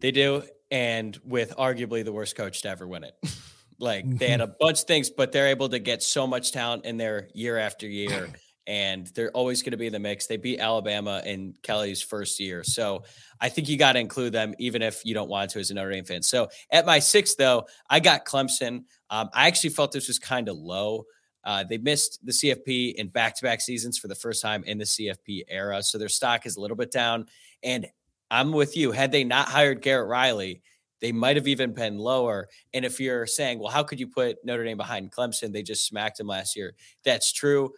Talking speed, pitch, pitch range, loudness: 235 wpm, 115 Hz, 105-130 Hz, -25 LUFS